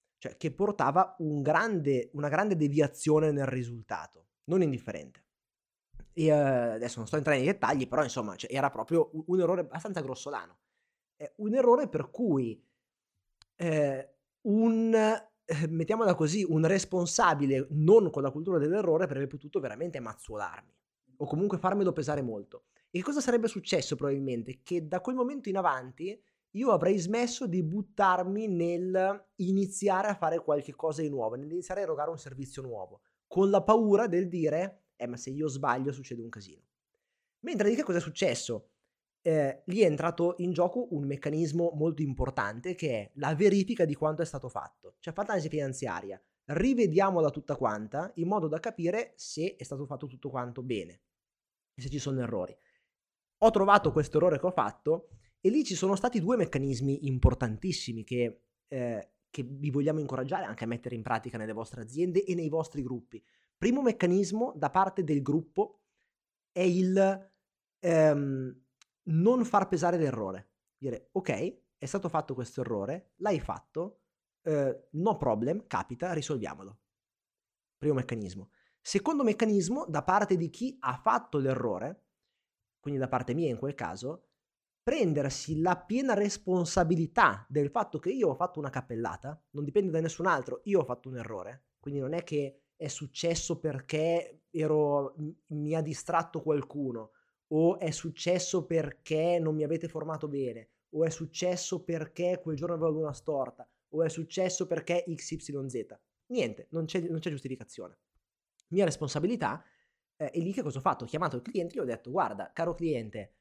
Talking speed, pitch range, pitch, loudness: 165 wpm, 135-185 Hz, 160 Hz, -31 LUFS